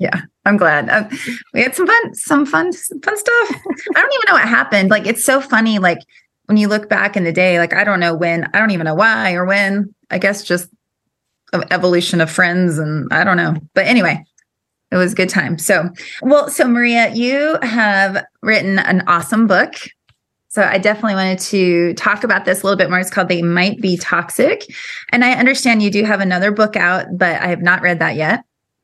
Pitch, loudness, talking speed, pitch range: 195 Hz, -14 LUFS, 215 wpm, 180-225 Hz